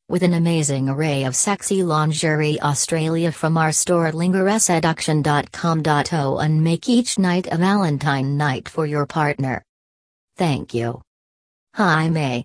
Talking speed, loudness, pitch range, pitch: 125 wpm, -19 LUFS, 140-170 Hz, 155 Hz